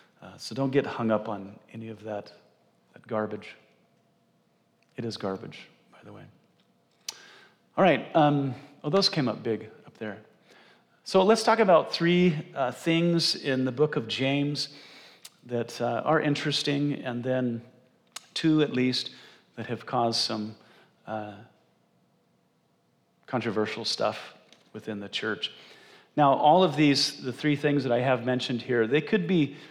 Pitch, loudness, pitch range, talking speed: 130 Hz, -26 LUFS, 115-150 Hz, 150 wpm